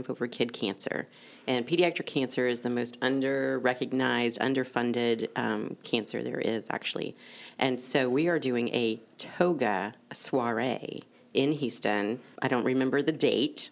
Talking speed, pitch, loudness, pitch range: 135 wpm, 125 Hz, -29 LUFS, 120-135 Hz